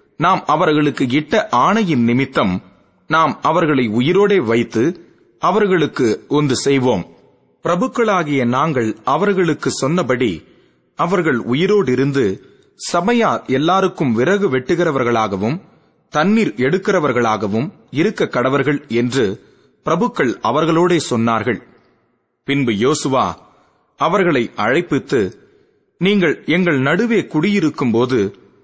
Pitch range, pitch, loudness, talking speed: 120-180 Hz, 140 Hz, -16 LUFS, 85 wpm